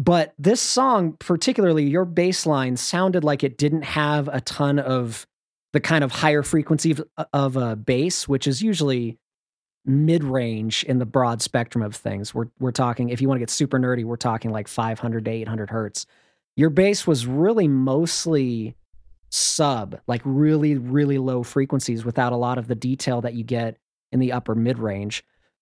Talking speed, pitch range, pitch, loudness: 175 wpm, 120-155 Hz, 130 Hz, -22 LUFS